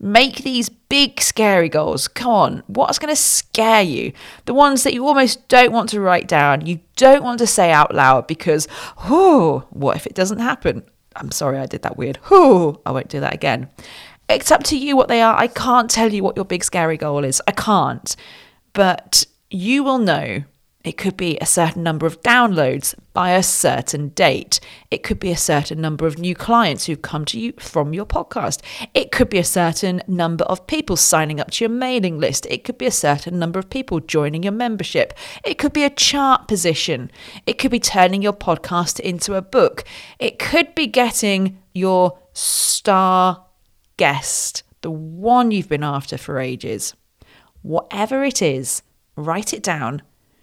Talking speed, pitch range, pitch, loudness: 190 wpm, 160-245 Hz, 190 Hz, -17 LUFS